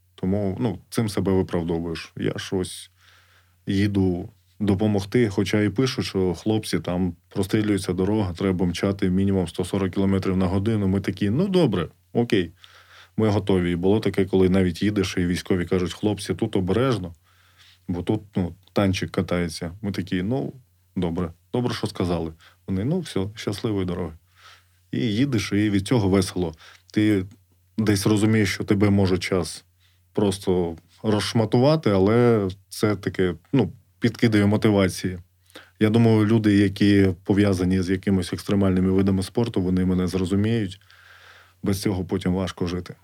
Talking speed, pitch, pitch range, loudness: 140 wpm, 95 Hz, 90-105 Hz, -23 LUFS